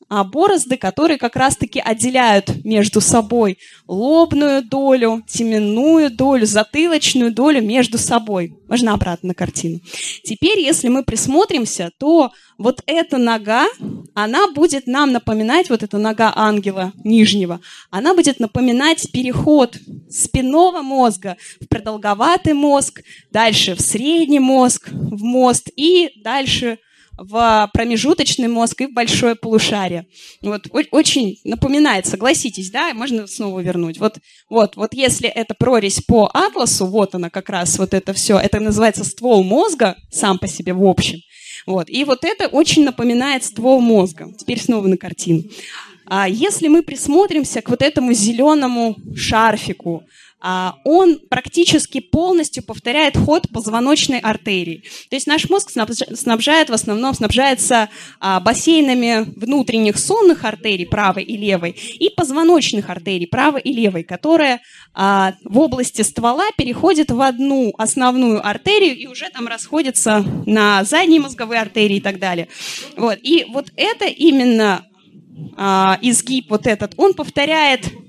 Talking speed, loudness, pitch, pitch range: 135 wpm, -15 LUFS, 235 Hz, 205-280 Hz